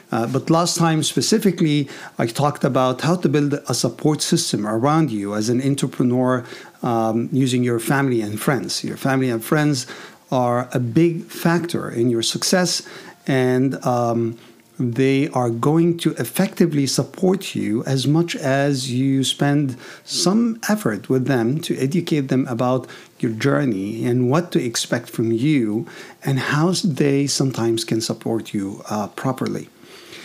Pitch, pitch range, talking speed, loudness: 135 Hz, 120-160 Hz, 150 wpm, -20 LUFS